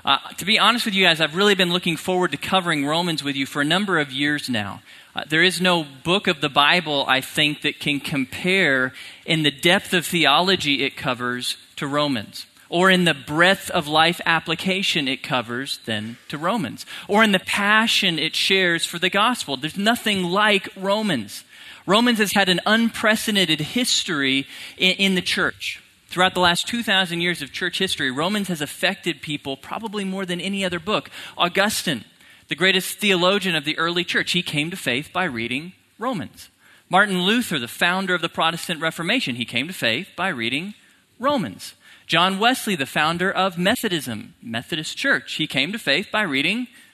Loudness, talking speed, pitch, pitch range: -20 LUFS, 180 wpm, 175 Hz, 150-195 Hz